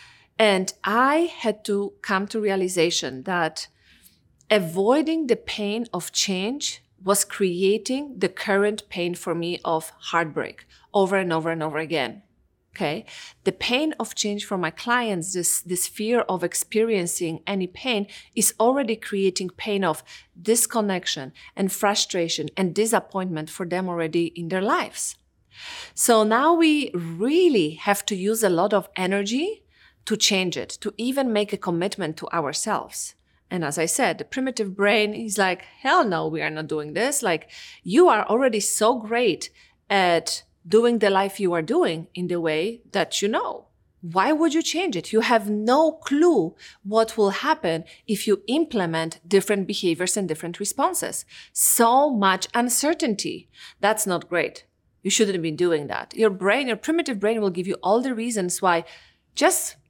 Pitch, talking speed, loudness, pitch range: 200 Hz, 160 wpm, -23 LUFS, 175-230 Hz